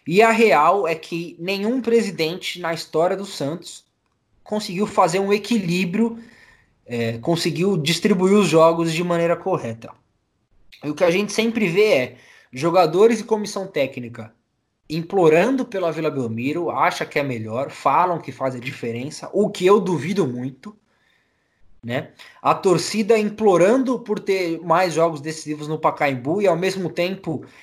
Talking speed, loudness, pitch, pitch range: 150 wpm, -20 LUFS, 175 Hz, 150-205 Hz